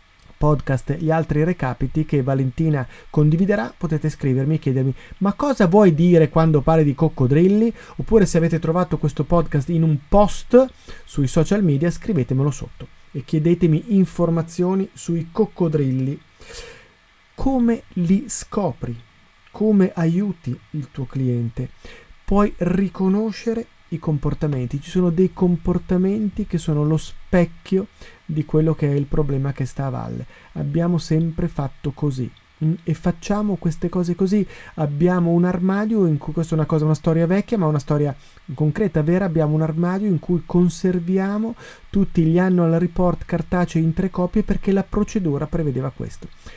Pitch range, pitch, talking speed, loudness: 150-185 Hz, 165 Hz, 145 wpm, -20 LUFS